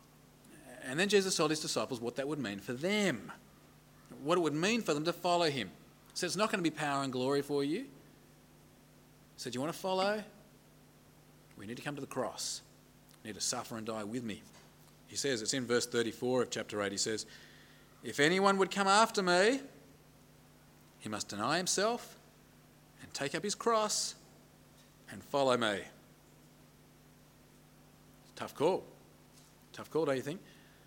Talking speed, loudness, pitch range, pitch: 180 wpm, -34 LUFS, 120-190 Hz, 145 Hz